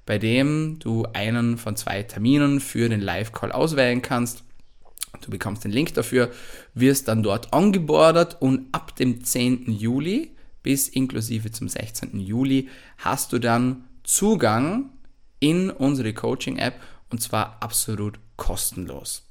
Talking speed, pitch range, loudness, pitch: 130 wpm, 115-135 Hz, -23 LUFS, 125 Hz